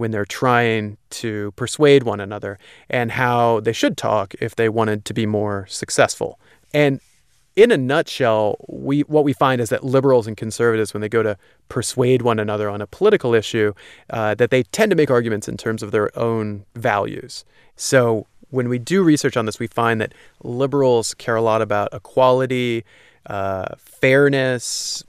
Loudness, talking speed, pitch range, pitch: -19 LUFS, 175 wpm, 105-130 Hz, 115 Hz